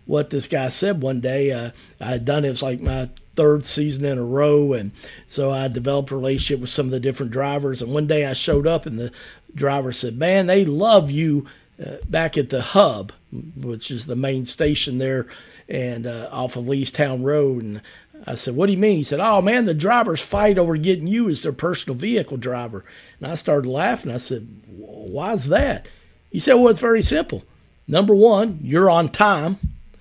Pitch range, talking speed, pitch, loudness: 125-165 Hz, 205 wpm, 140 Hz, -20 LUFS